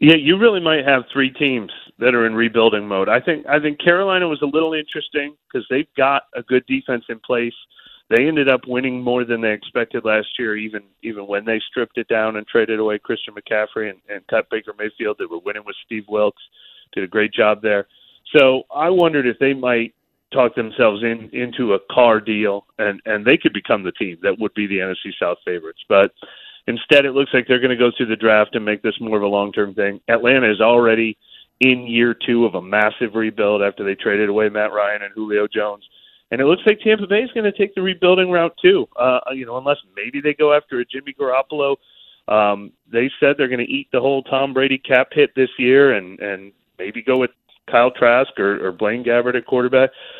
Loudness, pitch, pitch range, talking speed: -18 LUFS, 125 Hz, 105-140 Hz, 220 wpm